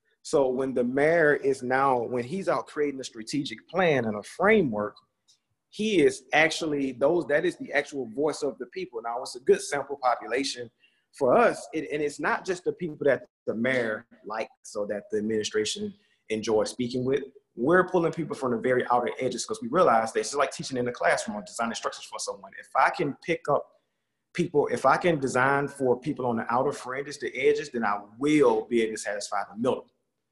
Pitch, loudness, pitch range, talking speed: 140 Hz, -27 LUFS, 120-175 Hz, 210 wpm